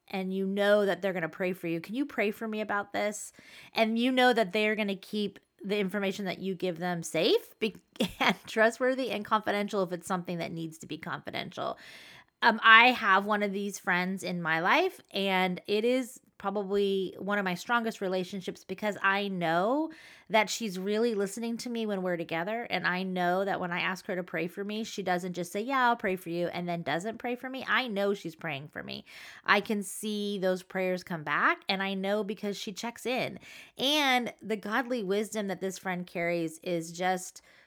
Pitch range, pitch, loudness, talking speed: 185-220 Hz, 200 Hz, -30 LUFS, 205 wpm